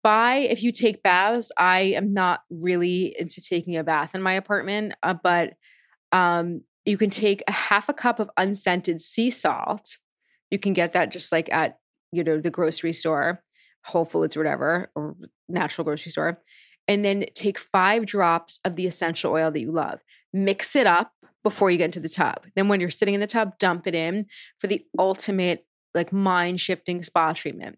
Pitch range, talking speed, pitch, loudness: 170-205 Hz, 190 wpm, 180 Hz, -23 LUFS